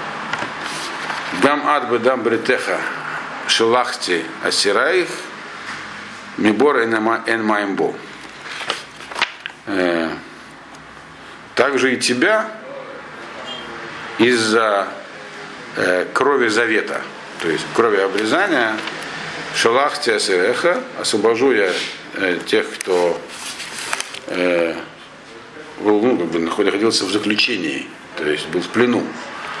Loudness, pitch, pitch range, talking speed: -18 LUFS, 115 Hz, 95-130 Hz, 75 wpm